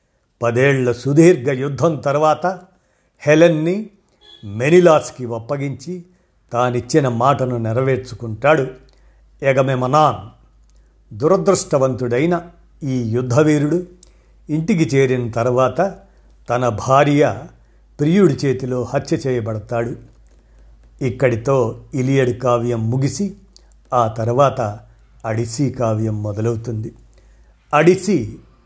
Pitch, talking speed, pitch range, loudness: 130 Hz, 70 wpm, 120-155 Hz, -17 LUFS